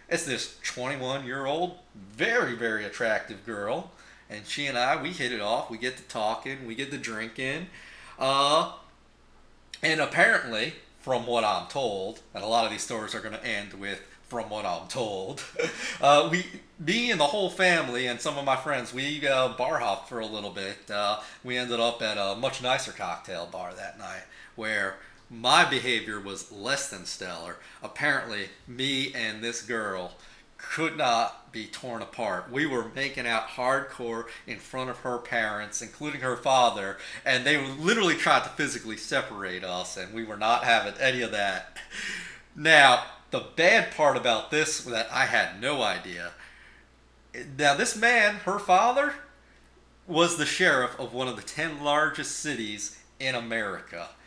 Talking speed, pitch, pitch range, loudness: 170 wpm, 125 Hz, 110-145 Hz, -27 LUFS